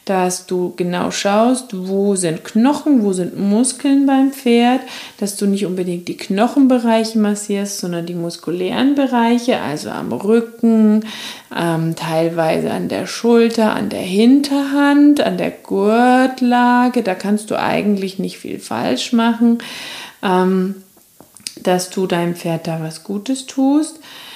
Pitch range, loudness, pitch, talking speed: 185-245 Hz, -16 LUFS, 220 Hz, 130 wpm